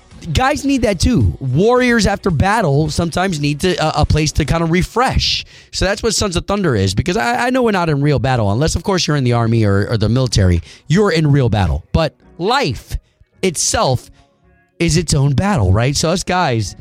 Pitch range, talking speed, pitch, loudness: 115-180 Hz, 210 wpm, 150 Hz, -15 LUFS